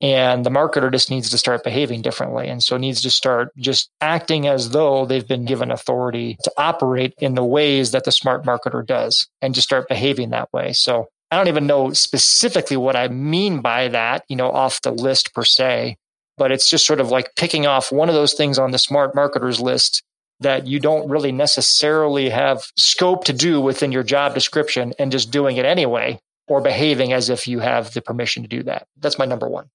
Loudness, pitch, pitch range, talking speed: -17 LUFS, 135 Hz, 125-145 Hz, 215 wpm